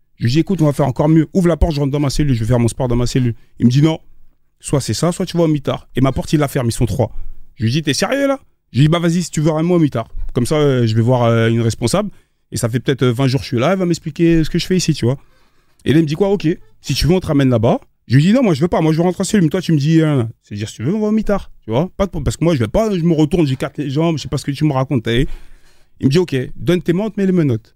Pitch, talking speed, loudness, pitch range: 150 Hz, 360 wpm, -16 LUFS, 125-170 Hz